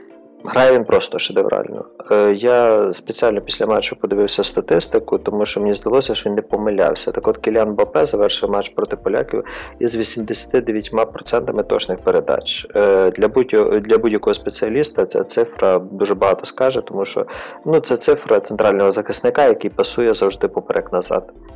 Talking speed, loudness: 140 wpm, -17 LUFS